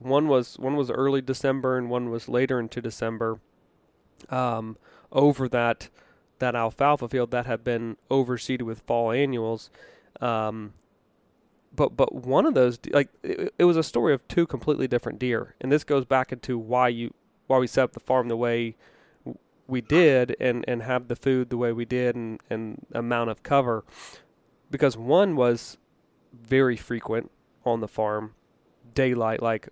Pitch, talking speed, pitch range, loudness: 125 Hz, 170 wpm, 115-130 Hz, -25 LUFS